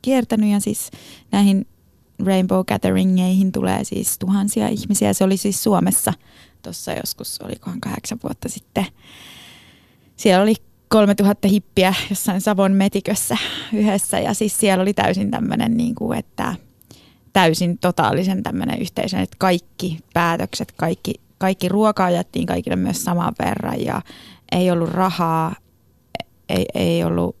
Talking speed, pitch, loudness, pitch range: 130 wpm, 195 Hz, -19 LUFS, 180-210 Hz